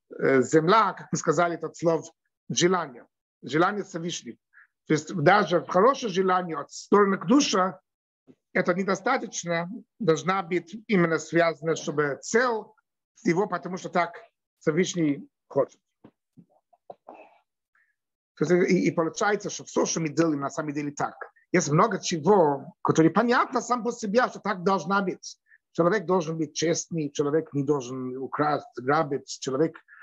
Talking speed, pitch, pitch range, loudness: 120 wpm, 170 Hz, 155-195 Hz, -25 LUFS